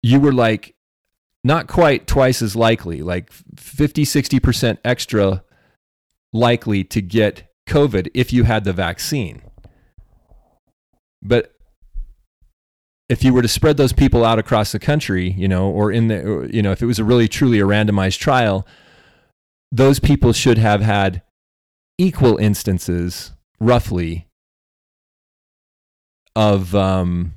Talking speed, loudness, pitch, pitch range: 125 wpm, -17 LUFS, 105 Hz, 95-125 Hz